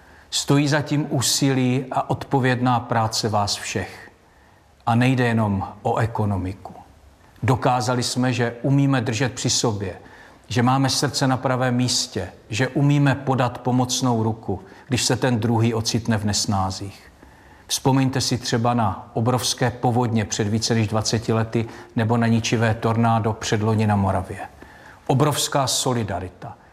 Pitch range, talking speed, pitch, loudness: 110-130 Hz, 130 wpm, 120 Hz, -21 LUFS